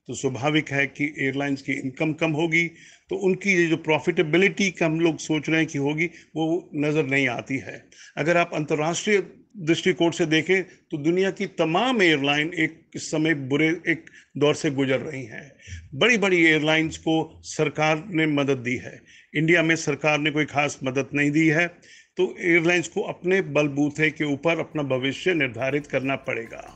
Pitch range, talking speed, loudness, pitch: 145-170 Hz, 170 wpm, -23 LUFS, 155 Hz